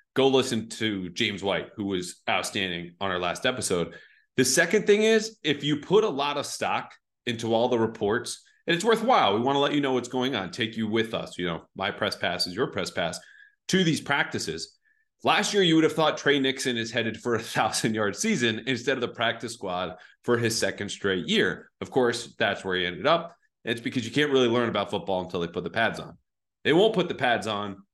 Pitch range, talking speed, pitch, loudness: 110-150 Hz, 230 wpm, 120 Hz, -26 LUFS